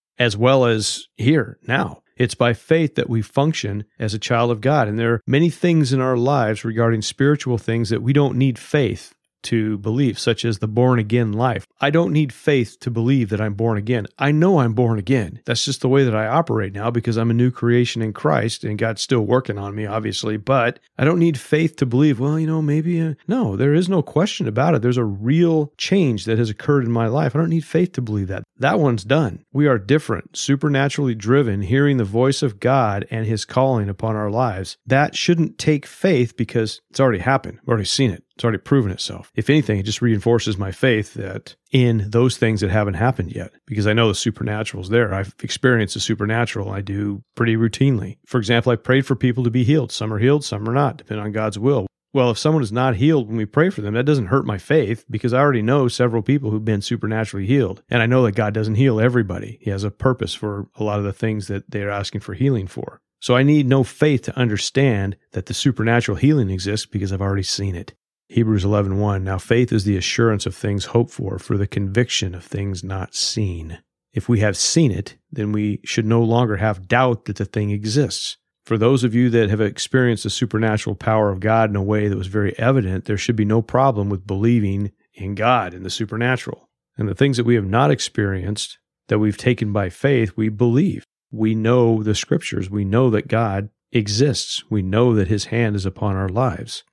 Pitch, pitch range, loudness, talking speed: 115 Hz, 105-130 Hz, -19 LUFS, 225 wpm